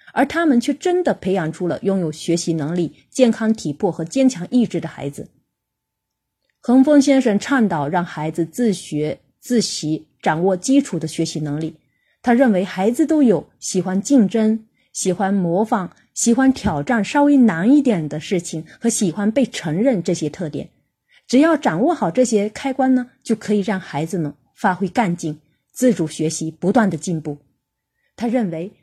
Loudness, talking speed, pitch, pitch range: -19 LUFS, 250 characters per minute, 195 Hz, 165-250 Hz